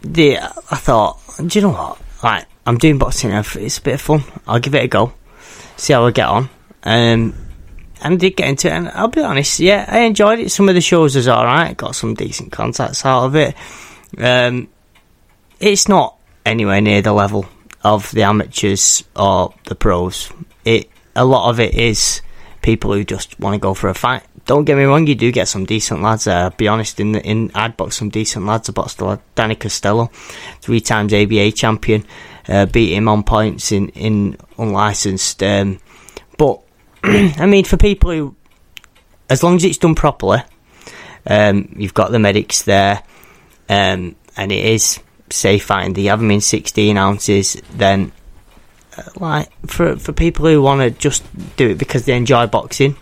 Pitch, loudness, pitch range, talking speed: 110 Hz, -14 LUFS, 100-135 Hz, 190 wpm